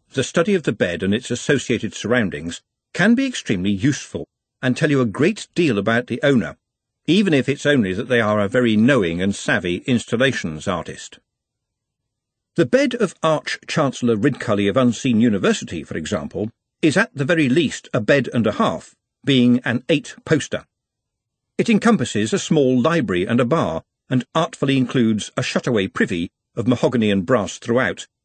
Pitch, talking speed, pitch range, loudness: 125 Hz, 170 wpm, 115-145 Hz, -19 LUFS